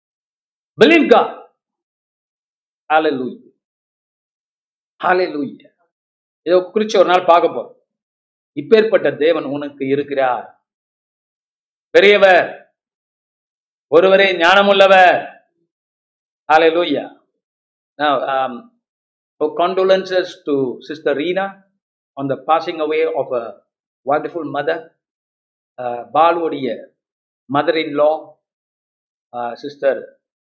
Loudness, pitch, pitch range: -15 LUFS, 155 Hz, 130-185 Hz